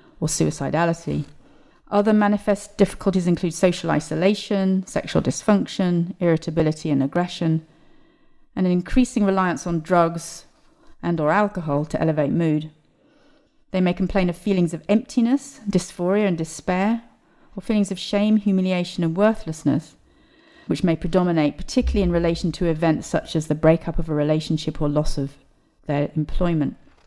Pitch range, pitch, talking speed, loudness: 160-205 Hz, 180 Hz, 135 wpm, -22 LUFS